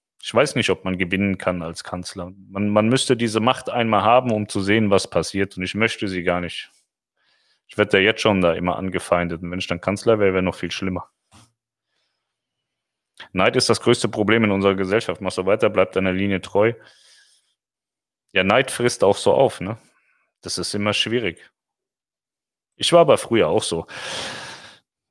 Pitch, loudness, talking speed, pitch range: 100 Hz, -20 LUFS, 185 wpm, 90-110 Hz